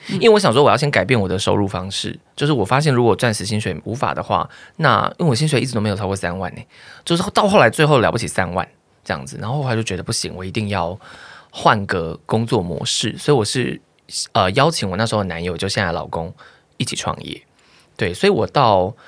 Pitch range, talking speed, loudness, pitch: 95-145 Hz, 350 characters per minute, -18 LUFS, 110 Hz